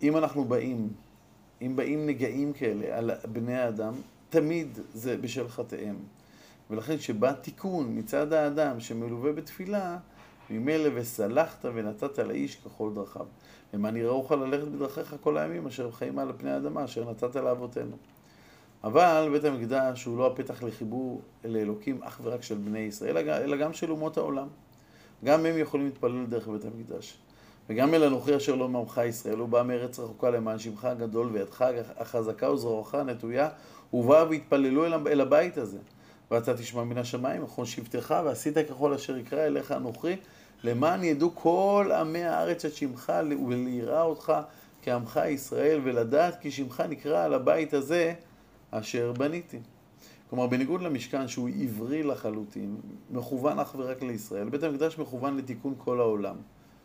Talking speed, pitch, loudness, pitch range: 145 wpm, 130 Hz, -29 LUFS, 115-150 Hz